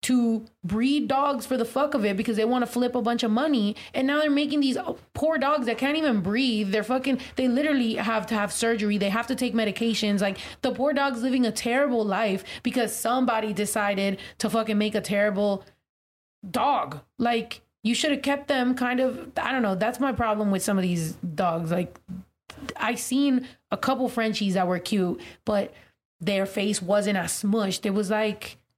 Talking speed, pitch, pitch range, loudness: 200 wpm, 230 Hz, 205-260 Hz, -25 LUFS